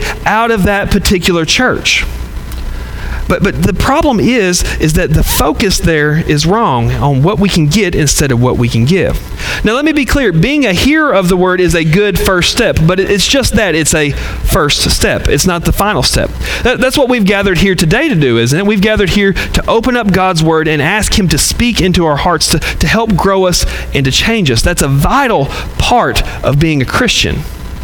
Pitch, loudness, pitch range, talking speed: 180 Hz, -10 LUFS, 145-205 Hz, 220 wpm